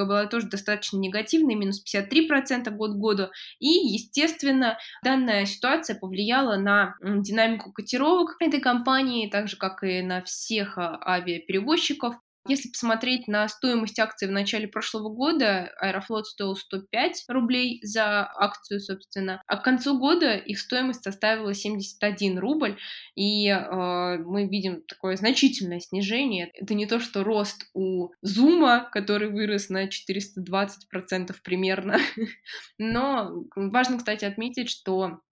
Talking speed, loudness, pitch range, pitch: 125 wpm, -25 LUFS, 195-245 Hz, 210 Hz